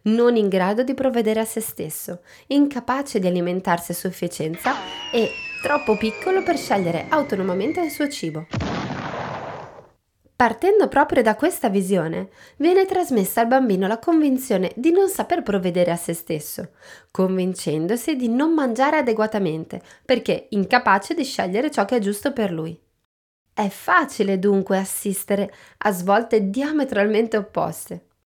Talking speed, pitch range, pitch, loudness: 135 wpm, 190-275 Hz, 215 Hz, -21 LUFS